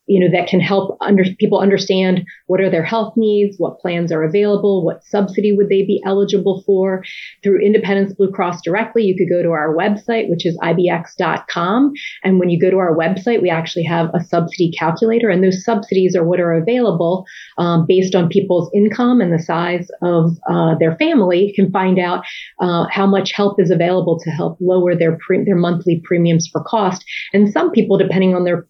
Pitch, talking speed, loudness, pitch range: 185 Hz, 200 wpm, -15 LUFS, 175-200 Hz